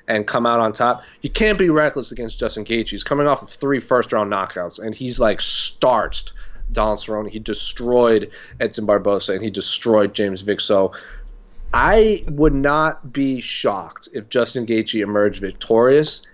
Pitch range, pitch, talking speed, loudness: 105-140 Hz, 115 Hz, 165 wpm, -19 LUFS